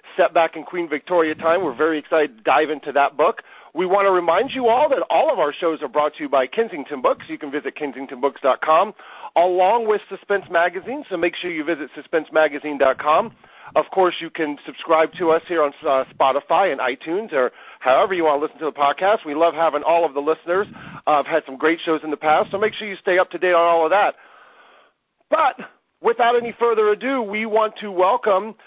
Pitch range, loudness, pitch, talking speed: 150-195 Hz, -20 LUFS, 165 Hz, 220 wpm